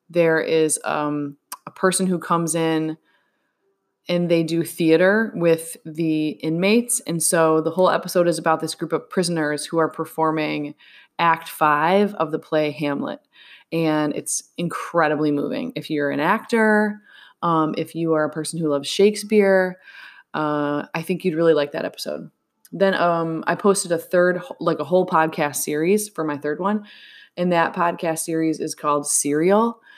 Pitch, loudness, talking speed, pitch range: 165 Hz, -21 LUFS, 165 wpm, 155-185 Hz